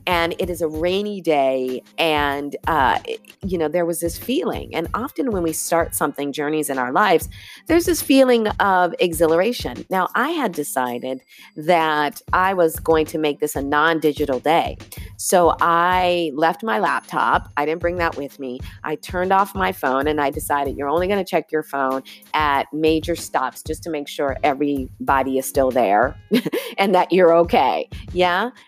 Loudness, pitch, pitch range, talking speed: -20 LUFS, 155 Hz, 140-180 Hz, 180 wpm